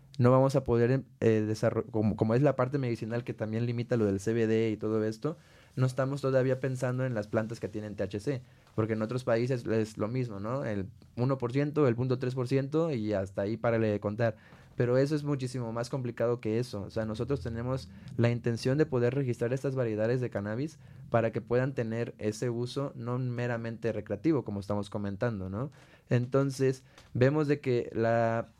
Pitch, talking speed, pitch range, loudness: 120 Hz, 185 wpm, 110-130 Hz, -31 LUFS